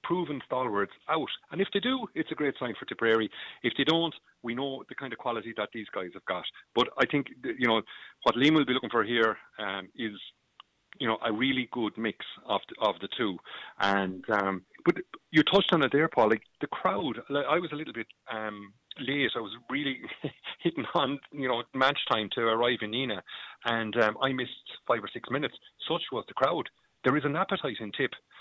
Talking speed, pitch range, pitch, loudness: 215 wpm, 110-155 Hz, 130 Hz, -30 LUFS